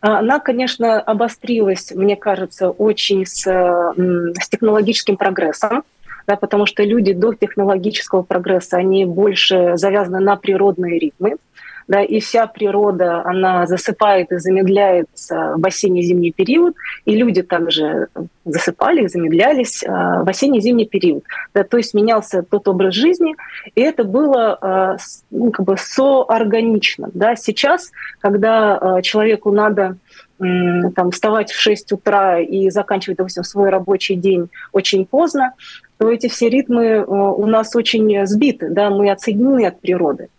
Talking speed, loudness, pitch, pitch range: 130 wpm, -15 LUFS, 200 Hz, 185-225 Hz